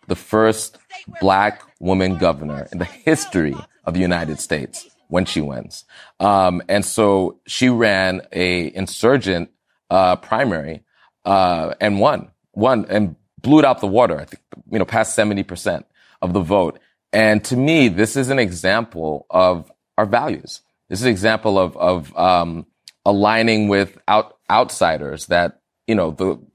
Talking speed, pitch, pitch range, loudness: 155 wpm, 95 Hz, 90-110 Hz, -18 LUFS